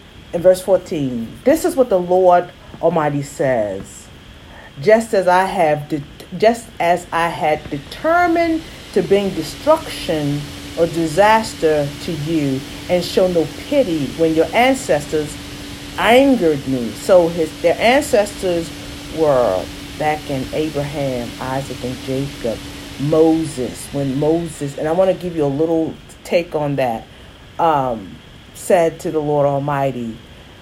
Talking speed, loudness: 125 wpm, -17 LUFS